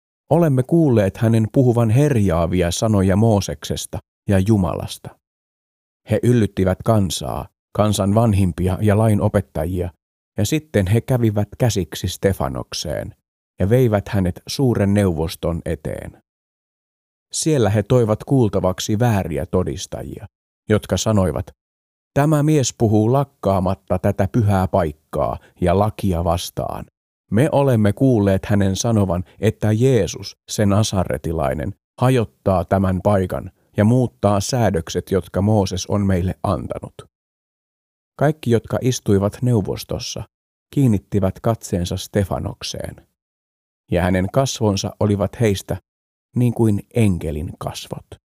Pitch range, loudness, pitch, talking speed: 90-115 Hz, -19 LUFS, 100 Hz, 100 wpm